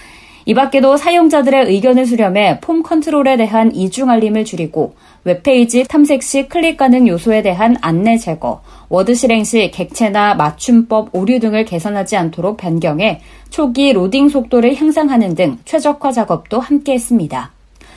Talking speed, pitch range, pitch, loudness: 330 characters per minute, 195-270 Hz, 235 Hz, -13 LUFS